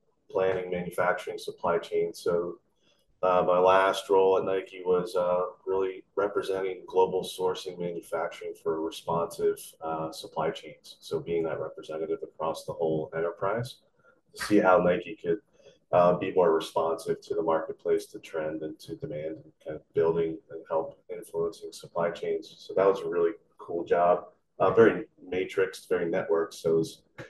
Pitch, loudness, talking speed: 130 Hz, -28 LUFS, 160 wpm